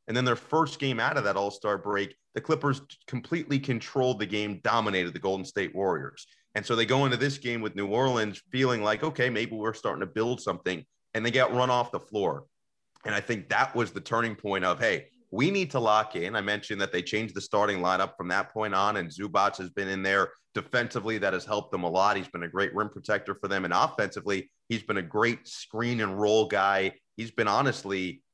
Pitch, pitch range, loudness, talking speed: 110 Hz, 100-125 Hz, -28 LUFS, 230 wpm